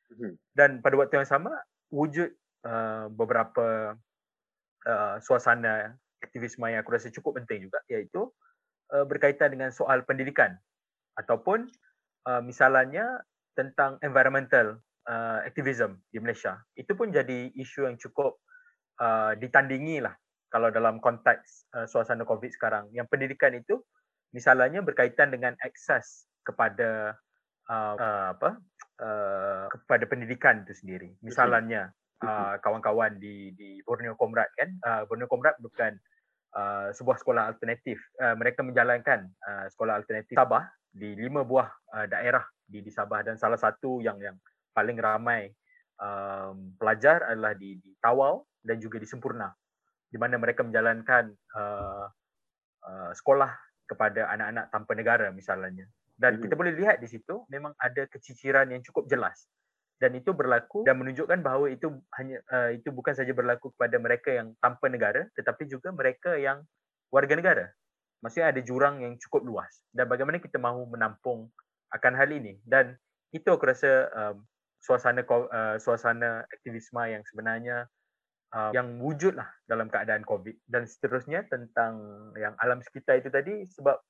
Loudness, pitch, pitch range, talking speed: -28 LUFS, 125 Hz, 110-140 Hz, 140 wpm